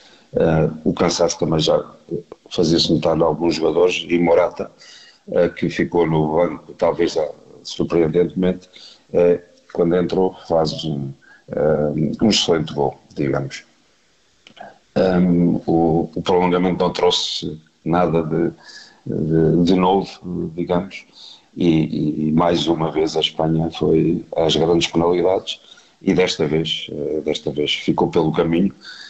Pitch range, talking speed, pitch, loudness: 80-90 Hz, 130 wpm, 85 Hz, -19 LUFS